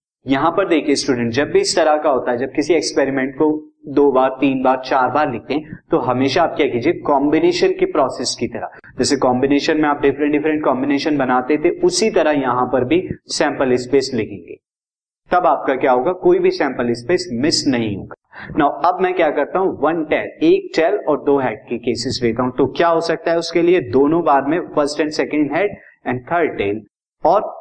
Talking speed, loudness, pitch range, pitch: 210 wpm, -17 LUFS, 130-165 Hz, 145 Hz